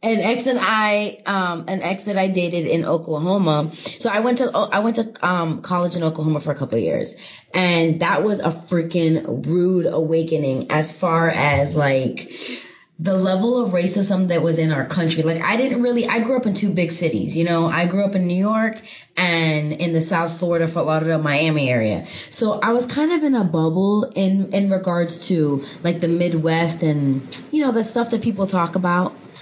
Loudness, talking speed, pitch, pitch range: -19 LUFS, 200 wpm, 175 Hz, 160-200 Hz